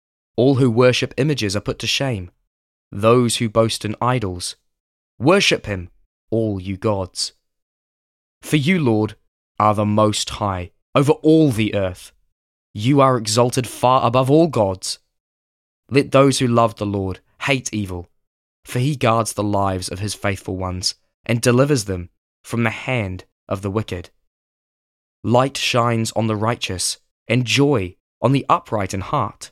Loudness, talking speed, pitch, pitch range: -19 LUFS, 150 wpm, 110 Hz, 95-125 Hz